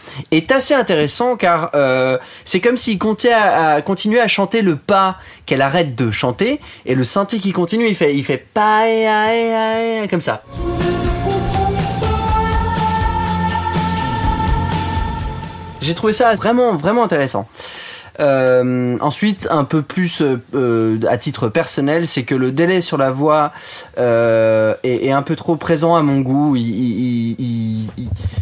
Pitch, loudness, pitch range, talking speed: 150 Hz, -16 LUFS, 125-205 Hz, 145 wpm